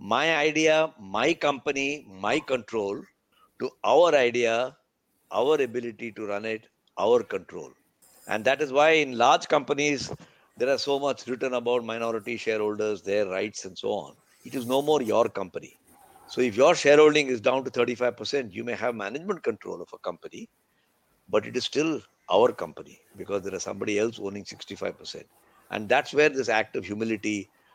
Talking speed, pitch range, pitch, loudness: 170 wpm, 110-145 Hz, 120 Hz, -25 LUFS